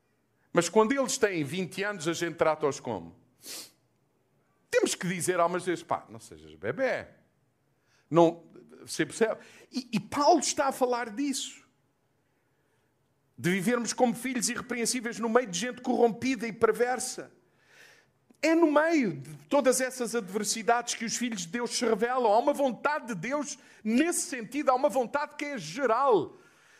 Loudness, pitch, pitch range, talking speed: -28 LUFS, 235 Hz, 170-265 Hz, 155 wpm